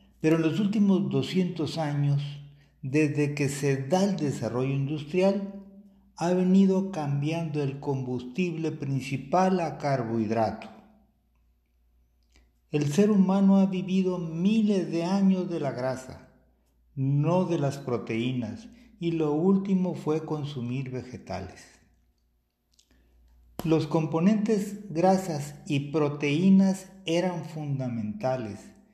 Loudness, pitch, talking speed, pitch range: -27 LUFS, 155 Hz, 100 wpm, 130-185 Hz